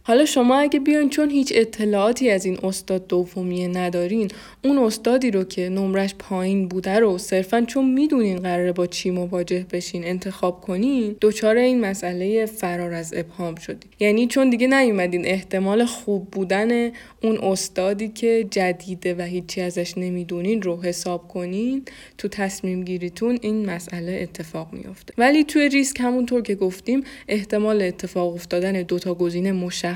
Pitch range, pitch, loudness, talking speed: 180-230 Hz, 195 Hz, -22 LUFS, 150 wpm